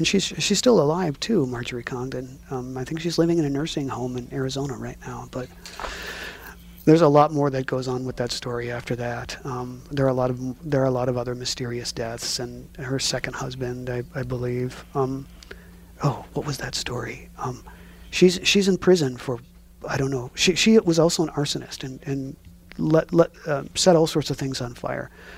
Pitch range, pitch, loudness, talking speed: 125-155 Hz, 130 Hz, -24 LUFS, 210 wpm